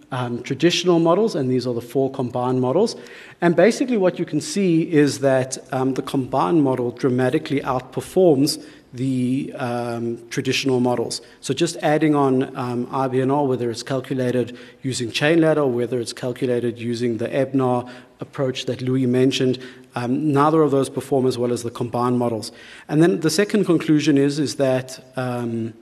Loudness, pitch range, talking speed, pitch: -20 LUFS, 125-145 Hz, 165 wpm, 130 Hz